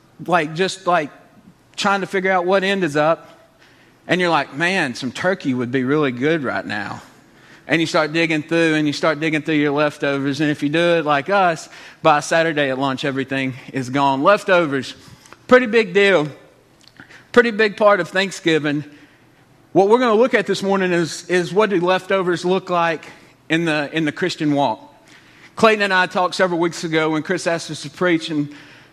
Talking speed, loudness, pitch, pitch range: 195 wpm, -18 LUFS, 165 Hz, 150-185 Hz